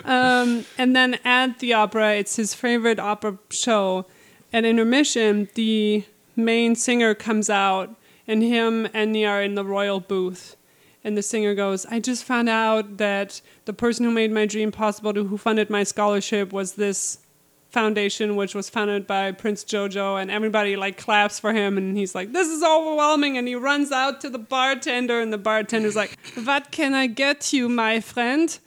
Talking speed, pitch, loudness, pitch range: 180 wpm, 220 Hz, -22 LUFS, 205-240 Hz